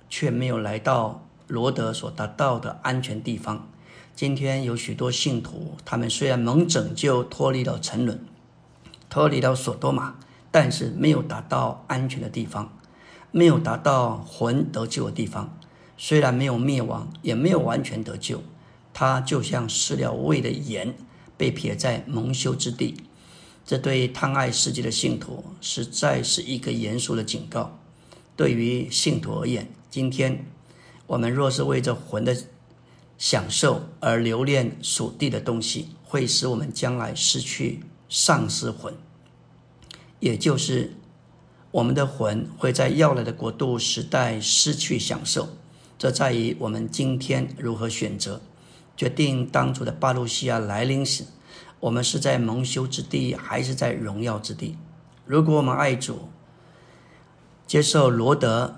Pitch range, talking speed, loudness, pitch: 120-150 Hz, 215 characters per minute, -24 LUFS, 130 Hz